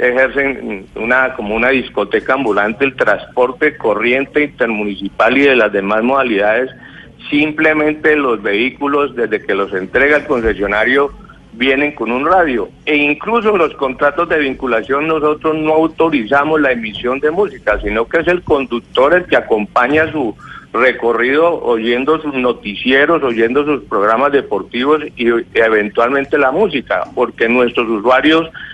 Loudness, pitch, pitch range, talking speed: -14 LUFS, 135 Hz, 115-150 Hz, 140 wpm